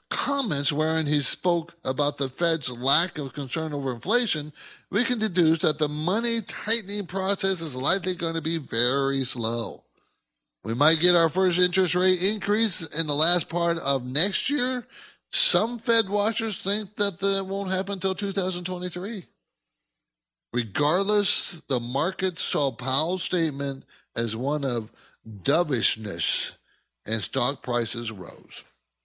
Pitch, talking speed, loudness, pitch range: 165 Hz, 135 wpm, -23 LUFS, 135-195 Hz